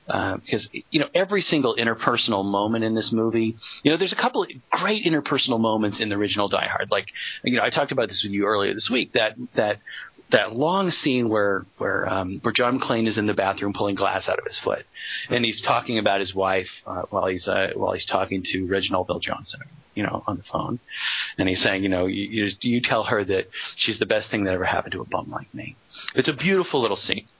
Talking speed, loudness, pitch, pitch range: 235 wpm, -23 LUFS, 110 Hz, 95-120 Hz